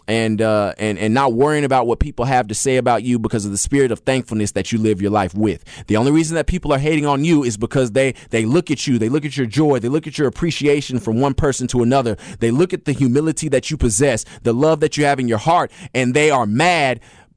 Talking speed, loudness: 265 wpm, -17 LUFS